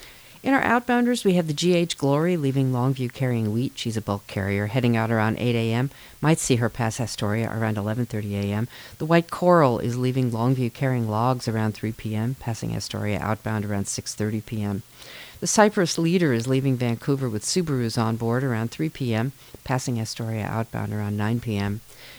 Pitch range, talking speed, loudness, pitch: 110-135 Hz, 175 wpm, -24 LUFS, 120 Hz